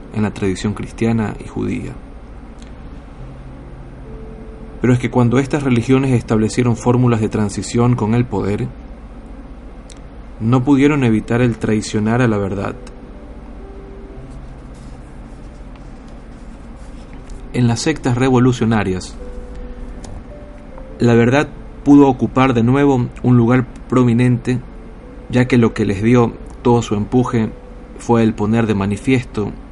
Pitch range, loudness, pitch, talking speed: 110-125 Hz, -16 LUFS, 120 Hz, 110 wpm